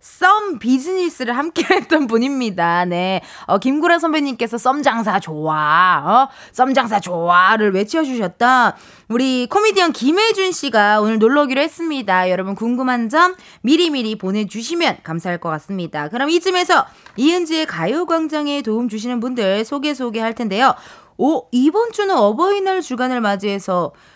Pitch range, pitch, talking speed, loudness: 210-320 Hz, 255 Hz, 330 characters per minute, -17 LUFS